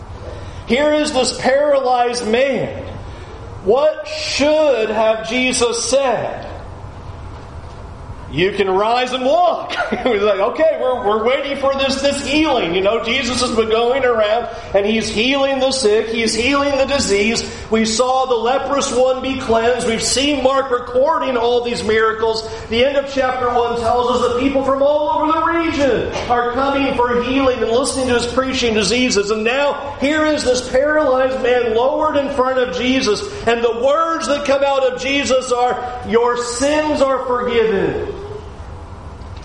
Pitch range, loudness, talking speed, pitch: 225-275 Hz, -16 LUFS, 160 wpm, 245 Hz